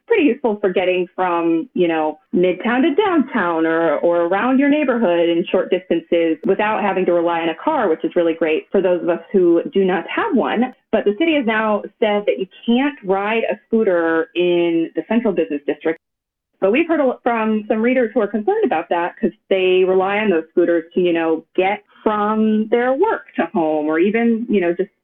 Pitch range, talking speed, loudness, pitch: 170-230 Hz, 205 wpm, -18 LUFS, 190 Hz